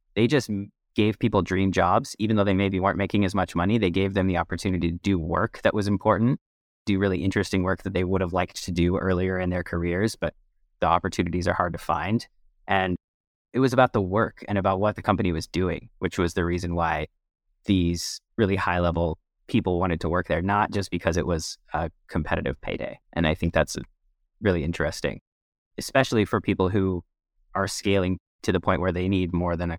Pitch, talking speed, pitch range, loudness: 95 Hz, 210 wpm, 85-100 Hz, -25 LUFS